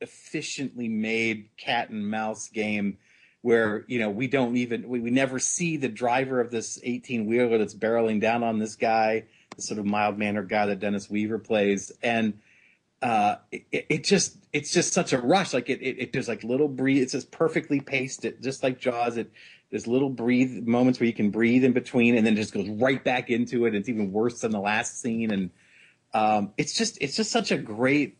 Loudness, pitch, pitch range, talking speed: -26 LUFS, 120 Hz, 110-130 Hz, 210 wpm